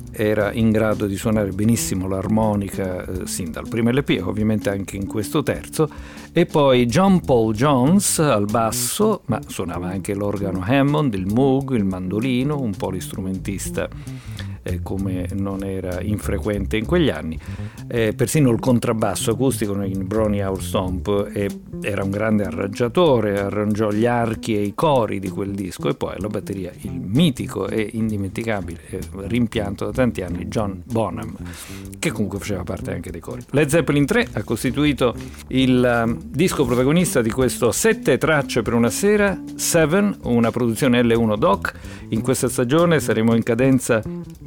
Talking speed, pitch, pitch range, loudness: 155 wpm, 110 Hz, 100-130 Hz, -20 LUFS